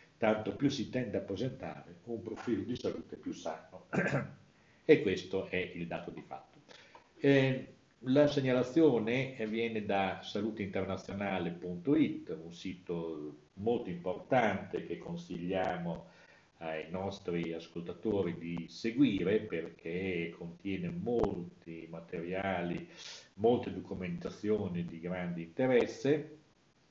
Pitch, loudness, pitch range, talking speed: 95 Hz, -35 LUFS, 85-115 Hz, 100 wpm